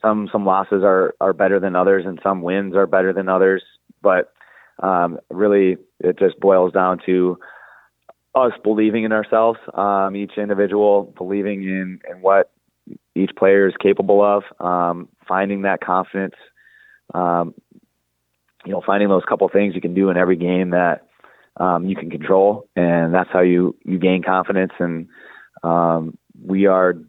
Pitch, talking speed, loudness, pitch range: 95 Hz, 160 wpm, -18 LUFS, 90-100 Hz